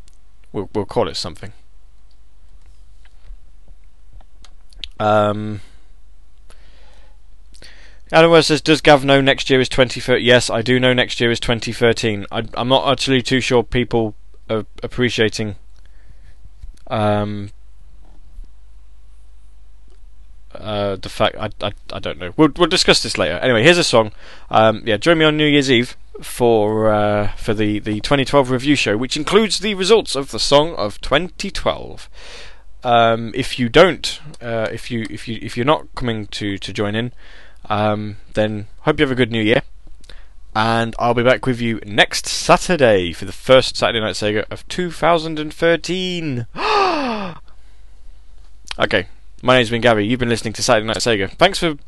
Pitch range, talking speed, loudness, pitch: 100-135 Hz, 155 wpm, -17 LUFS, 115 Hz